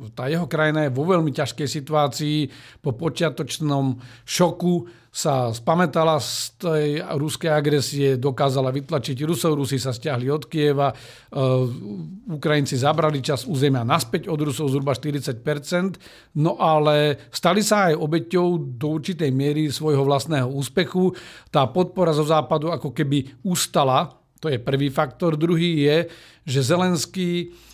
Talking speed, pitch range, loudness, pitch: 130 wpm, 140-165 Hz, -22 LUFS, 150 Hz